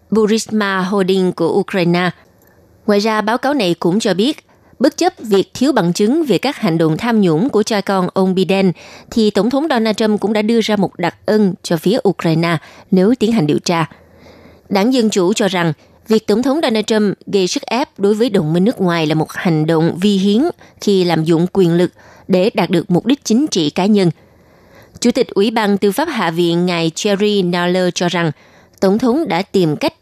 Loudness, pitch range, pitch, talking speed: -15 LUFS, 175-220 Hz, 195 Hz, 210 wpm